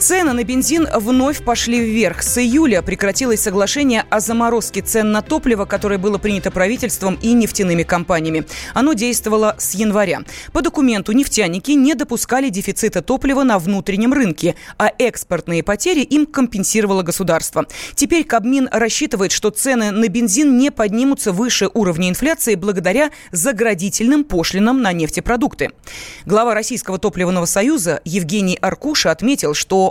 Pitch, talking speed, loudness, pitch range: 220 Hz, 135 wpm, -16 LUFS, 195-260 Hz